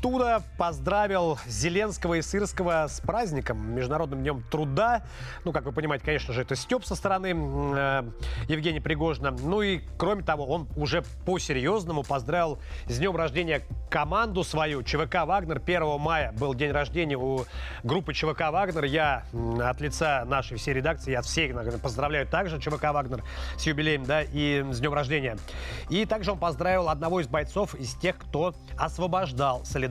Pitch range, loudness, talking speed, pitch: 135-175 Hz, -28 LUFS, 155 wpm, 155 Hz